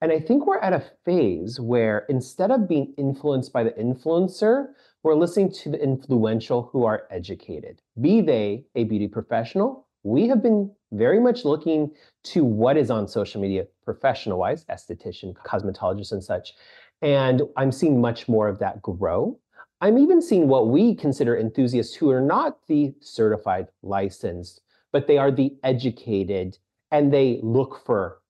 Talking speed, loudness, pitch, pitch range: 160 wpm, -22 LUFS, 135 Hz, 115-165 Hz